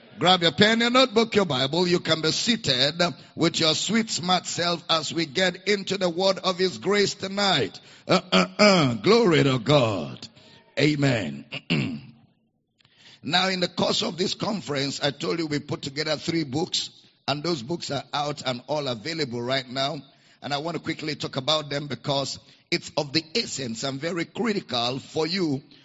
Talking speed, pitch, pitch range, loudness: 175 wpm, 160 Hz, 140-185 Hz, -24 LUFS